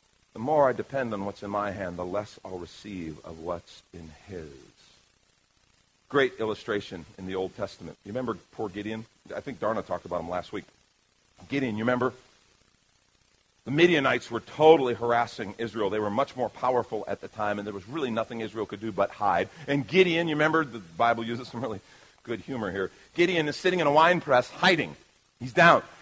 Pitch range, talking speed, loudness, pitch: 105-135 Hz, 195 wpm, -27 LUFS, 115 Hz